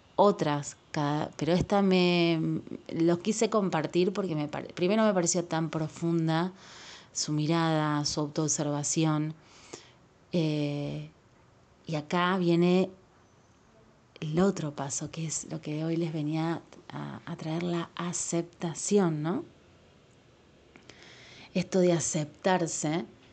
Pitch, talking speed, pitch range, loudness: 165 Hz, 105 wpm, 150-175 Hz, -29 LUFS